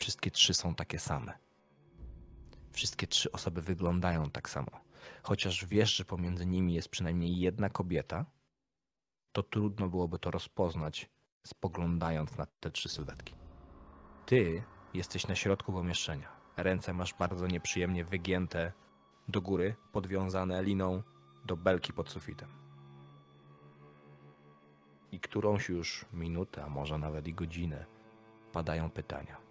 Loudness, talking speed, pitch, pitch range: -35 LUFS, 120 wpm, 85 Hz, 75-95 Hz